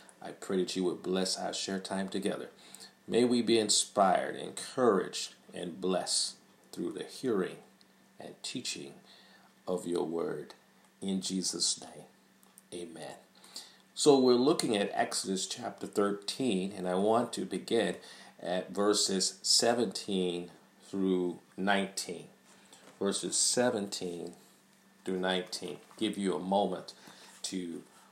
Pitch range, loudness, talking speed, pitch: 90-105 Hz, -32 LUFS, 115 wpm, 95 Hz